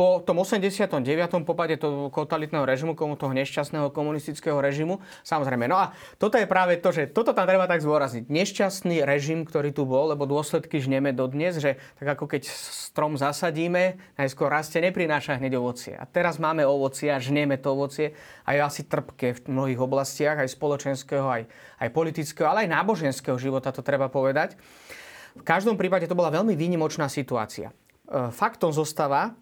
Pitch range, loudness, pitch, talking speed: 140-175 Hz, -25 LUFS, 150 Hz, 165 wpm